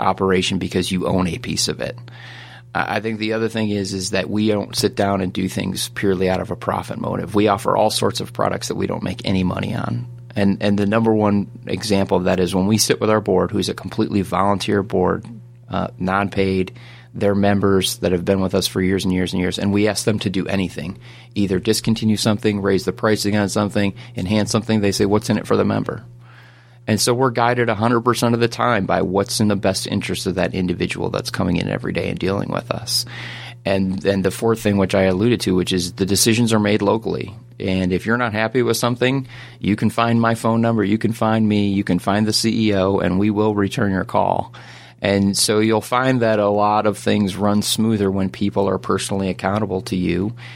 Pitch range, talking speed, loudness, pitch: 95-115 Hz, 225 wpm, -19 LUFS, 105 Hz